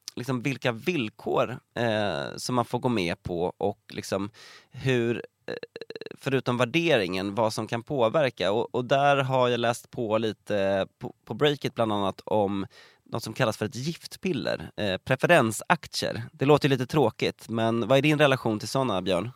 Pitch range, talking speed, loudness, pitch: 110-140 Hz, 175 wpm, -26 LUFS, 125 Hz